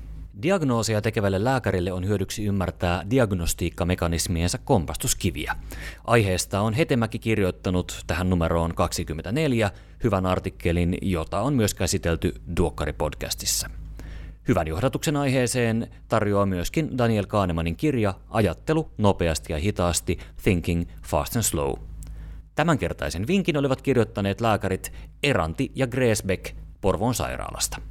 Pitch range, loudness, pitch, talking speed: 85-115 Hz, -25 LUFS, 95 Hz, 105 wpm